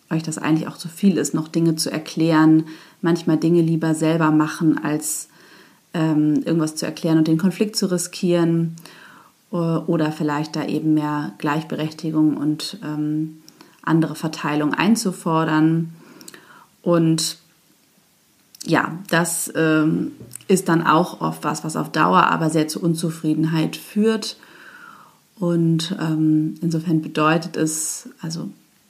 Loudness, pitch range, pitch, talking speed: -20 LUFS, 155-170 Hz, 160 Hz, 125 wpm